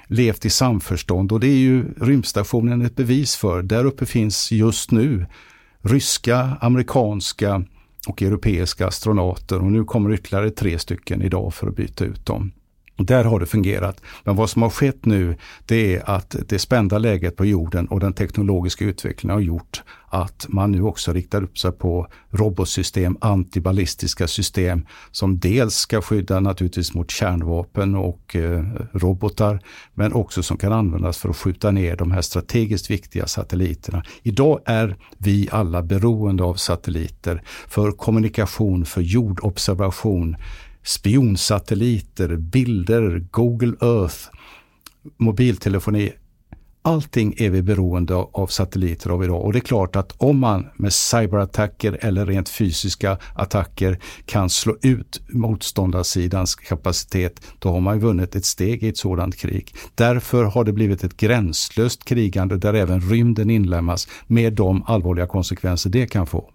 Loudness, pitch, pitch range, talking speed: -20 LUFS, 100 Hz, 90-110 Hz, 145 wpm